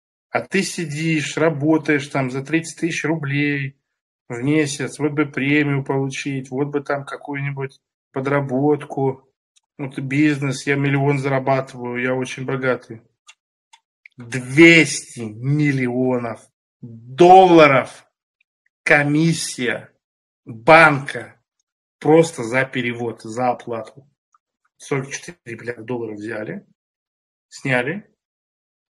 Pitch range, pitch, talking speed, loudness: 125-150 Hz, 140 Hz, 90 wpm, -18 LUFS